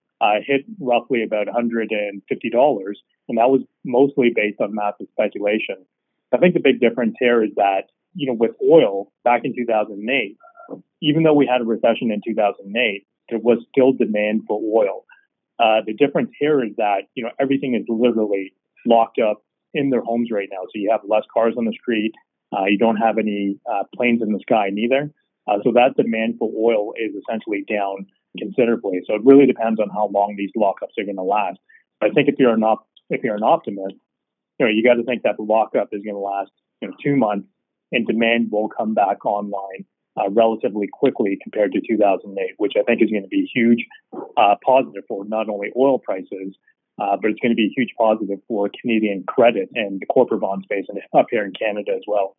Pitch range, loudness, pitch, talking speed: 105-125 Hz, -19 LUFS, 115 Hz, 210 wpm